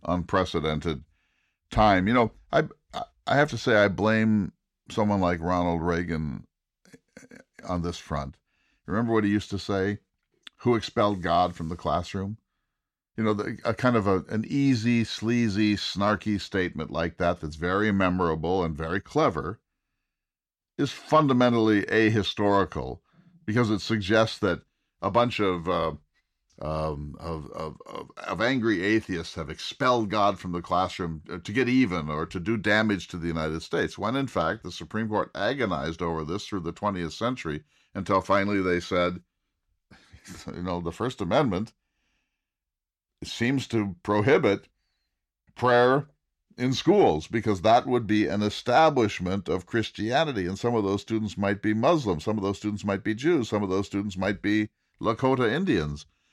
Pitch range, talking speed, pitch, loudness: 85-110 Hz, 155 wpm, 100 Hz, -26 LUFS